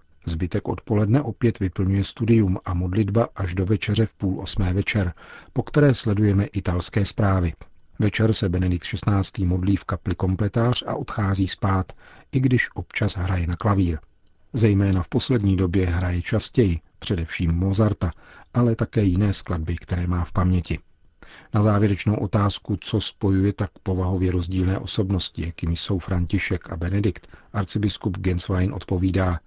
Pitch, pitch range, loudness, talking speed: 95 Hz, 90-105 Hz, -23 LUFS, 140 wpm